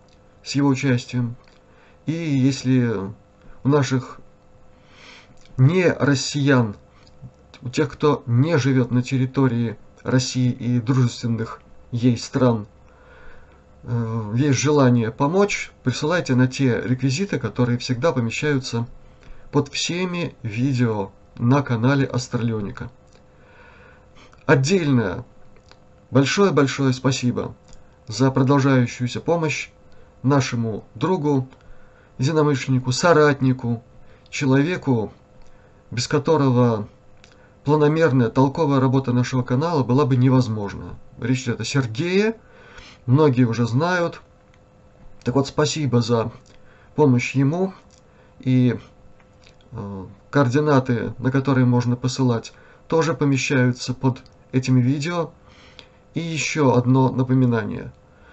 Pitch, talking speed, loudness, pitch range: 130 Hz, 85 wpm, -20 LUFS, 115-140 Hz